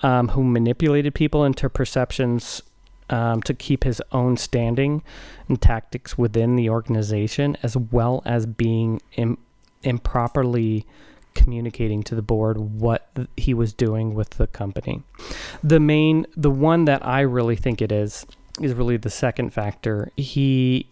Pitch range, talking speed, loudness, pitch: 115-135 Hz, 145 wpm, -22 LUFS, 120 Hz